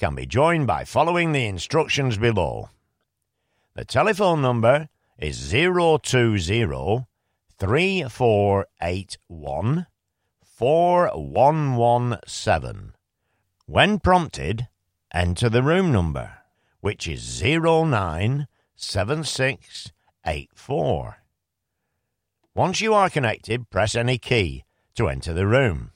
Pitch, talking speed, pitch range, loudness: 120 Hz, 80 wpm, 95-150 Hz, -22 LUFS